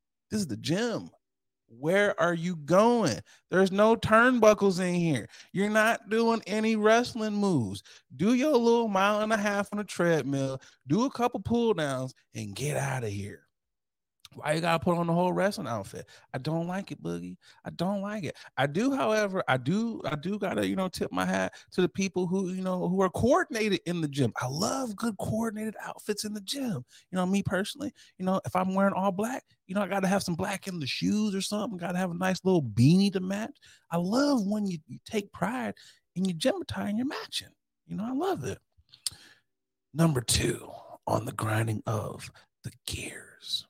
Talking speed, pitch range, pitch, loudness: 200 wpm, 155-215 Hz, 190 Hz, -28 LUFS